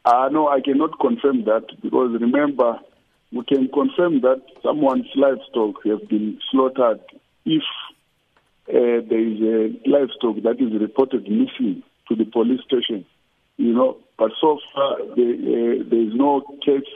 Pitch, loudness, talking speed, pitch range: 135 Hz, -20 LUFS, 150 wpm, 115-145 Hz